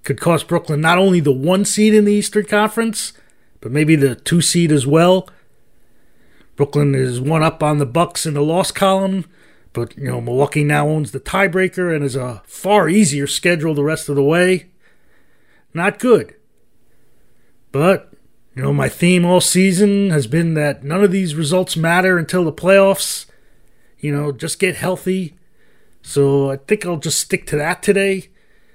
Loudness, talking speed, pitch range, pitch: -16 LUFS, 175 wpm, 145-190 Hz, 170 Hz